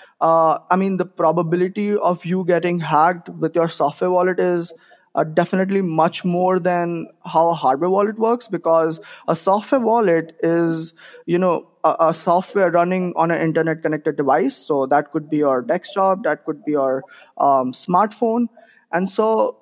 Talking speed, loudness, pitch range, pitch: 165 wpm, -19 LUFS, 160-185 Hz, 175 Hz